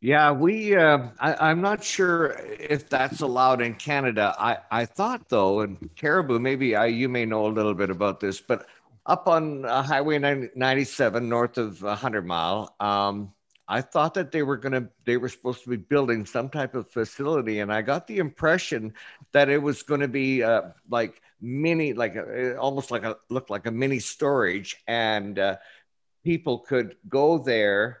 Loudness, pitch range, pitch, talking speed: -25 LUFS, 110-145 Hz, 130 Hz, 180 wpm